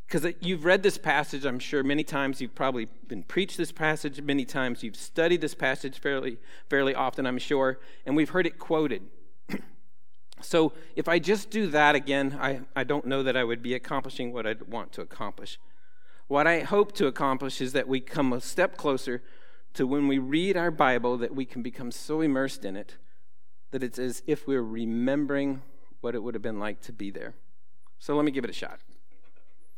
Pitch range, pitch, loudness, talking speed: 130-155 Hz, 140 Hz, -28 LUFS, 200 wpm